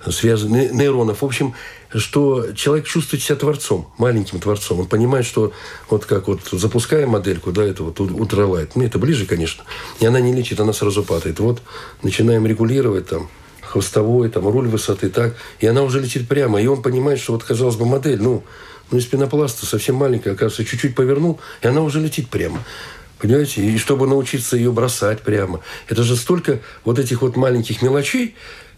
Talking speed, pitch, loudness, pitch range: 180 wpm, 120 Hz, -18 LUFS, 105-135 Hz